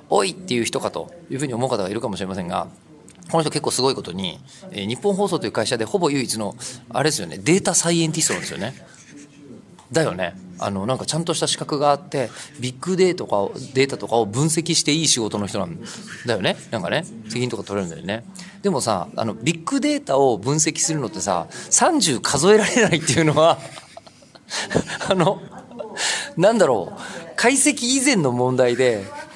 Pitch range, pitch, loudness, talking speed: 125-180 Hz, 150 Hz, -20 LUFS, 380 characters per minute